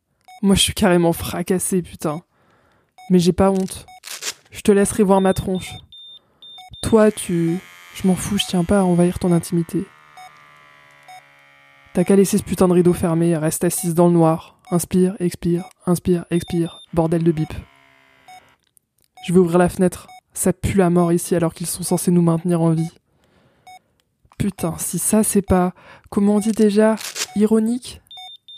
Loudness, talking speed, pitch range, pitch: -18 LUFS, 160 wpm, 170-195 Hz, 180 Hz